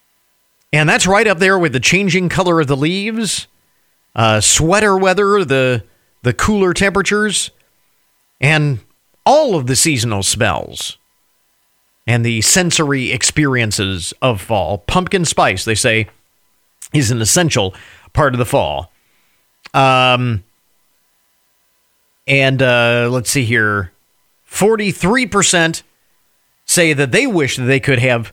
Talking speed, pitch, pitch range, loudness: 125 wpm, 135 Hz, 115-180 Hz, -14 LUFS